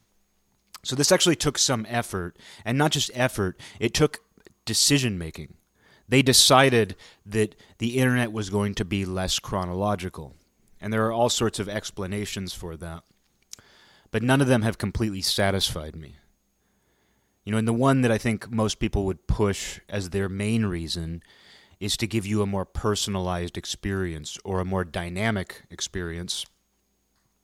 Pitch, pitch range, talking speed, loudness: 100 Hz, 90-115 Hz, 155 wpm, -24 LUFS